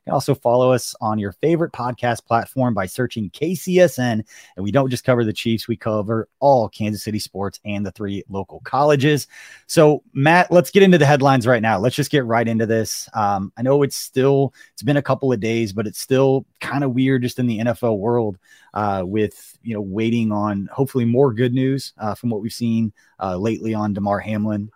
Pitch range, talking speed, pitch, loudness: 105-135 Hz, 215 wpm, 115 Hz, -19 LUFS